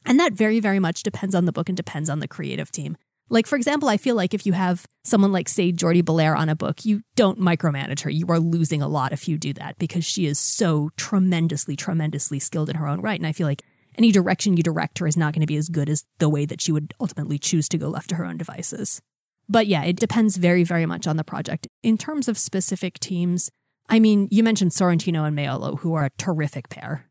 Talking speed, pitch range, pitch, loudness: 250 wpm, 155-195 Hz, 170 Hz, -22 LUFS